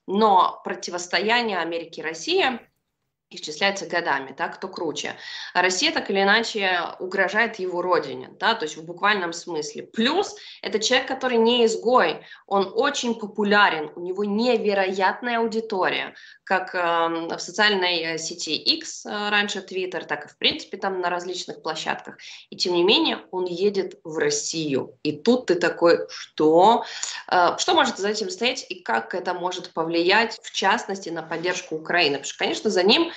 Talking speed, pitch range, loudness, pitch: 160 wpm, 175-225 Hz, -23 LUFS, 195 Hz